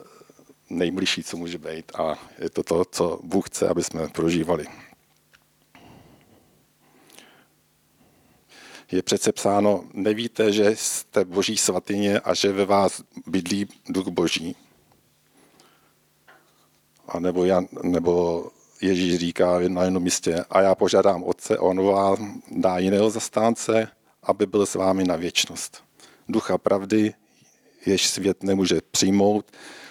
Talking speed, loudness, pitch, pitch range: 115 wpm, -23 LUFS, 95 Hz, 90-105 Hz